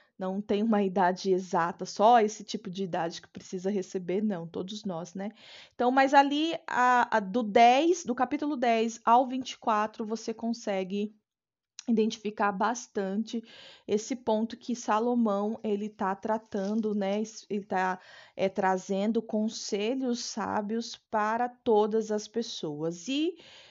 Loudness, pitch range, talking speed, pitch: -29 LUFS, 200-235 Hz, 130 wpm, 215 Hz